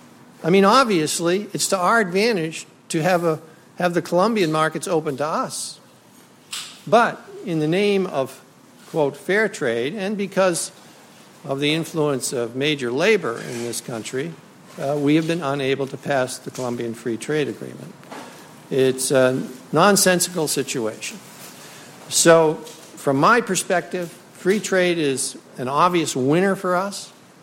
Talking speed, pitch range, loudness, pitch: 140 wpm, 135-185 Hz, -20 LUFS, 160 Hz